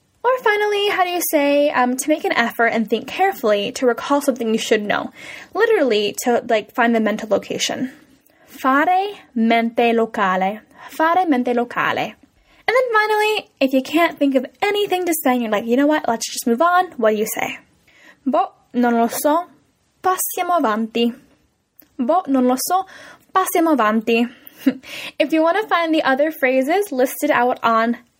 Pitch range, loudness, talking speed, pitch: 235-345 Hz, -18 LUFS, 170 wpm, 275 Hz